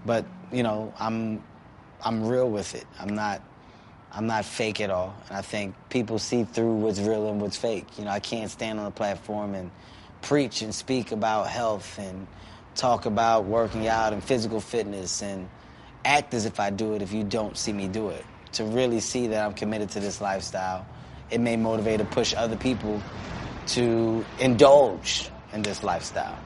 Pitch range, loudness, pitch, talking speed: 100-115 Hz, -27 LUFS, 110 Hz, 190 wpm